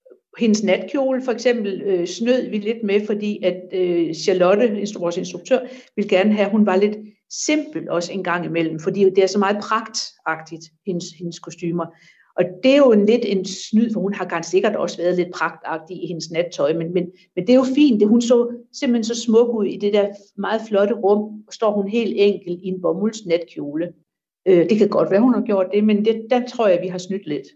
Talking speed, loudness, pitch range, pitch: 225 wpm, -19 LUFS, 180-225 Hz, 200 Hz